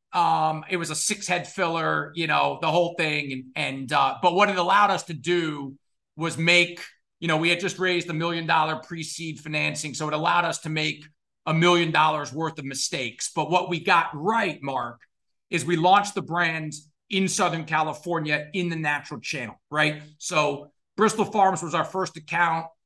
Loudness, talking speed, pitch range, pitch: -24 LUFS, 195 wpm, 150-175 Hz, 165 Hz